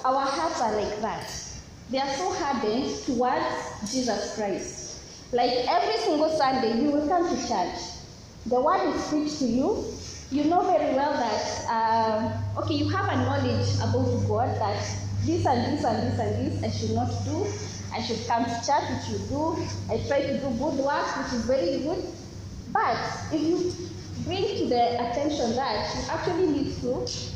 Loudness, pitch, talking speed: -27 LUFS, 245 Hz, 180 wpm